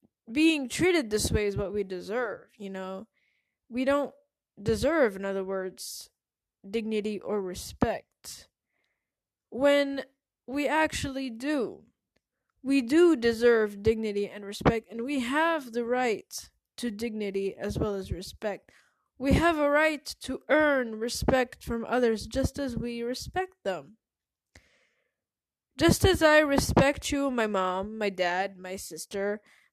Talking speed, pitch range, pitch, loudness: 130 wpm, 205-280 Hz, 240 Hz, -28 LUFS